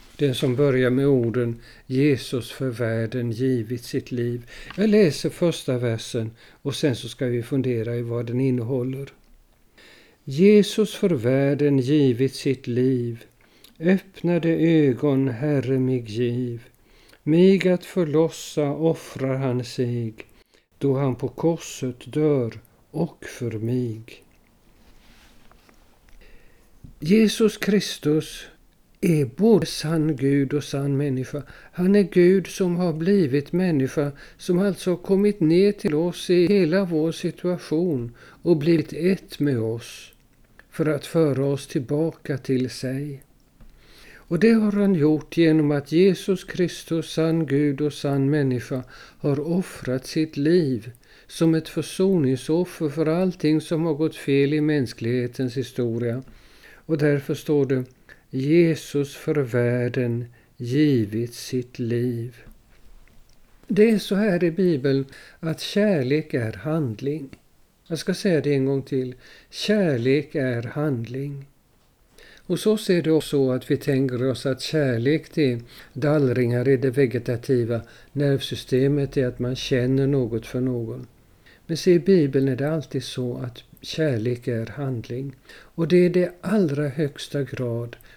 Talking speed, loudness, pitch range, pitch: 135 wpm, -23 LUFS, 125-165 Hz, 140 Hz